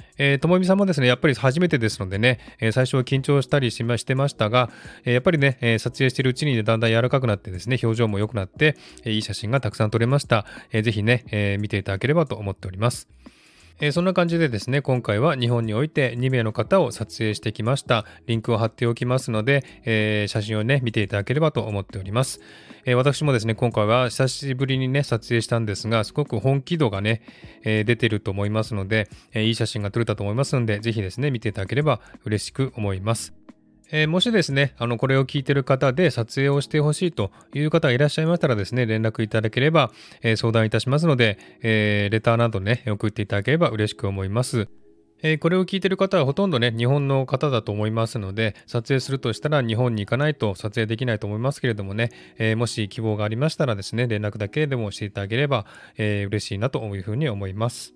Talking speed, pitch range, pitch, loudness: 455 characters per minute, 110-140 Hz, 120 Hz, -22 LUFS